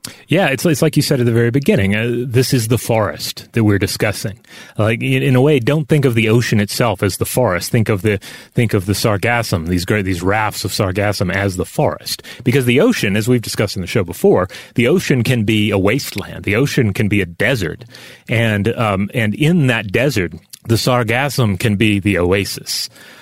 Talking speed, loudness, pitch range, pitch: 215 wpm, -16 LUFS, 105-130 Hz, 115 Hz